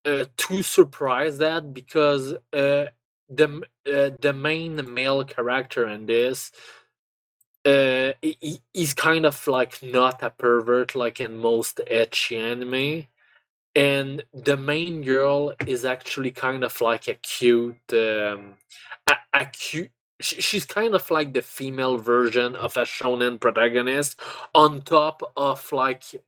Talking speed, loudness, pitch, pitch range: 135 wpm, -23 LUFS, 135 Hz, 120-150 Hz